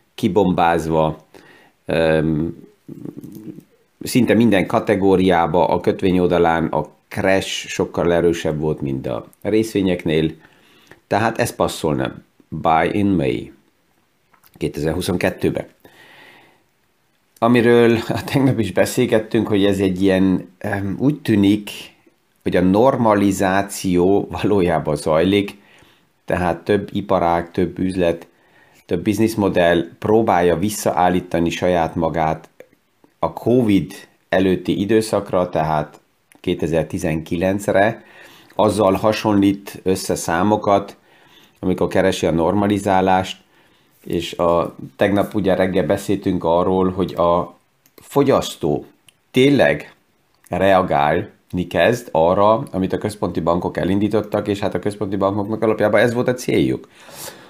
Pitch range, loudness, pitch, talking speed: 85-105 Hz, -18 LUFS, 95 Hz, 95 wpm